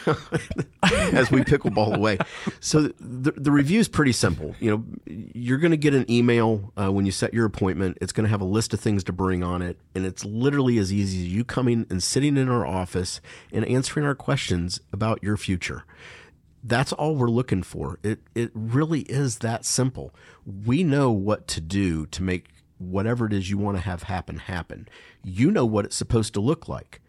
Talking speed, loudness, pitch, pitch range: 205 wpm, -24 LUFS, 110 Hz, 95-130 Hz